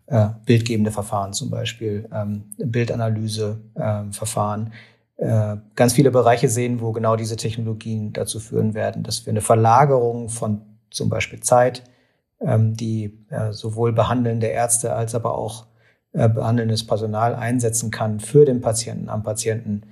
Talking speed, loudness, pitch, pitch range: 120 wpm, -21 LUFS, 115 Hz, 110-120 Hz